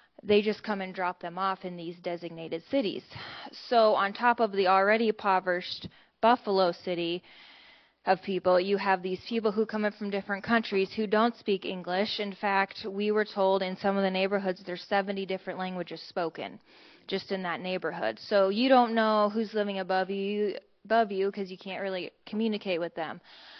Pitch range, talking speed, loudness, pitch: 185-210 Hz, 185 wpm, -29 LUFS, 195 Hz